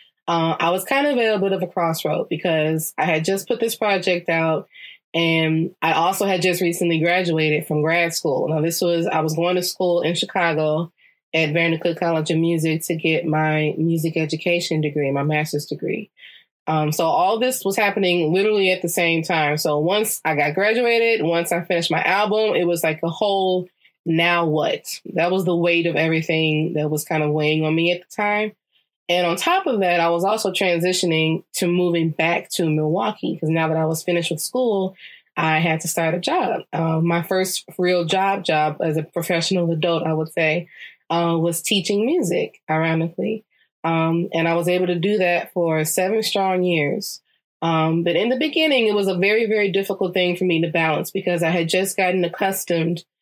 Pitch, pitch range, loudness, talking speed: 170 Hz, 160-190 Hz, -20 LUFS, 195 wpm